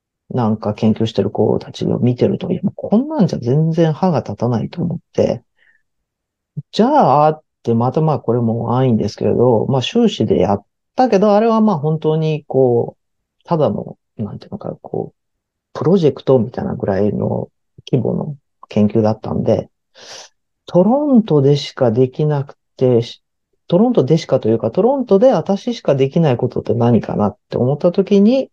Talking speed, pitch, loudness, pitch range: 340 characters per minute, 145 Hz, -16 LUFS, 120-190 Hz